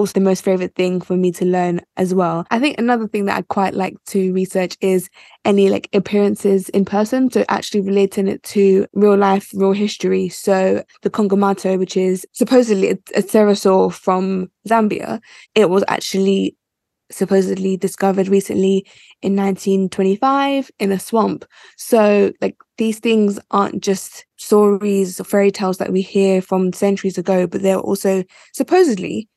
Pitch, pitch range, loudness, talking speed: 195 Hz, 190-205 Hz, -17 LUFS, 160 wpm